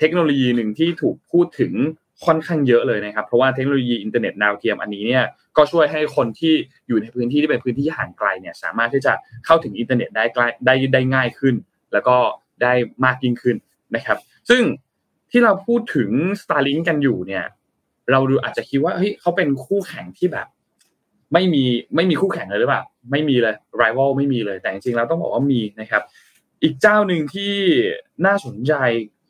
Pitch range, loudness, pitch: 120-165 Hz, -19 LUFS, 135 Hz